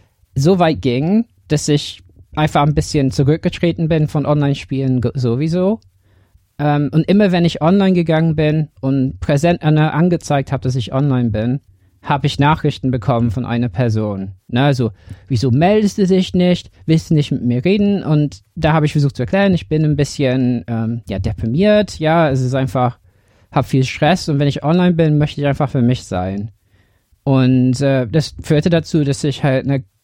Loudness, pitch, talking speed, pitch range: -16 LUFS, 140 Hz, 180 wpm, 120-160 Hz